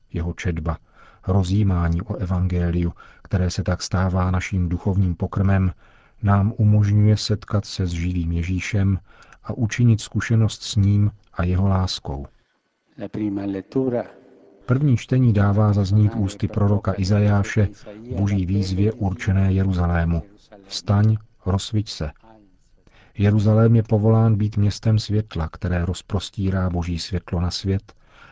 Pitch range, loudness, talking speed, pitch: 90-105 Hz, -21 LUFS, 110 wpm, 100 Hz